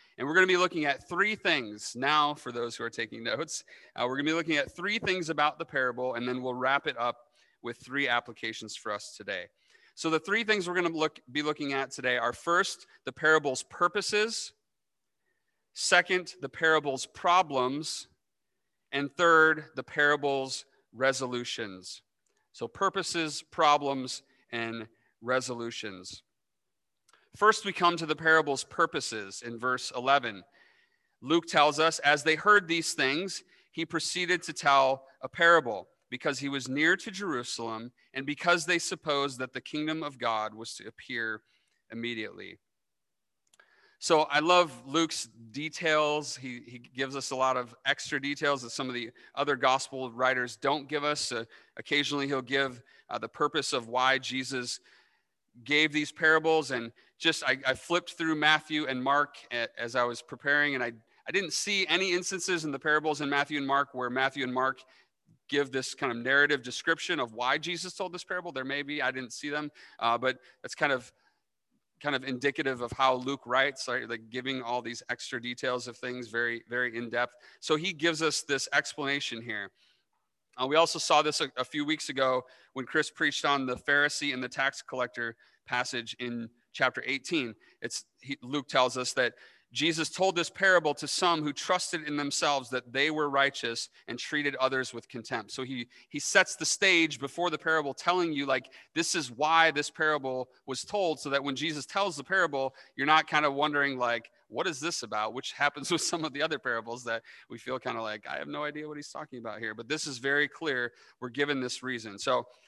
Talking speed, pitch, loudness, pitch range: 185 wpm, 140 Hz, -29 LUFS, 125-155 Hz